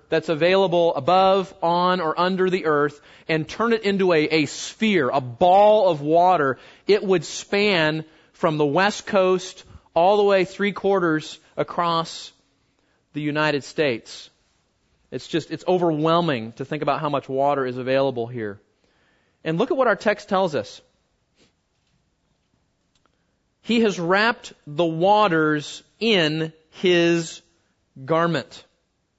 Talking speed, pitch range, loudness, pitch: 130 wpm, 150-190 Hz, -21 LUFS, 170 Hz